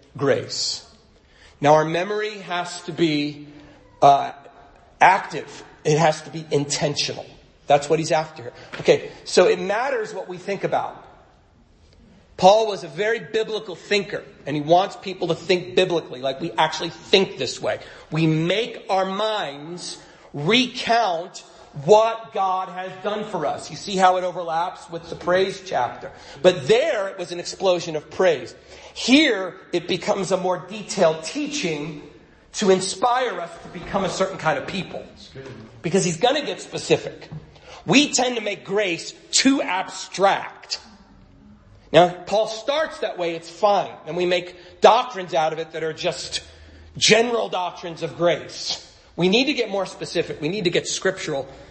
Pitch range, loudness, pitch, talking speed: 160-200 Hz, -21 LUFS, 180 Hz, 155 wpm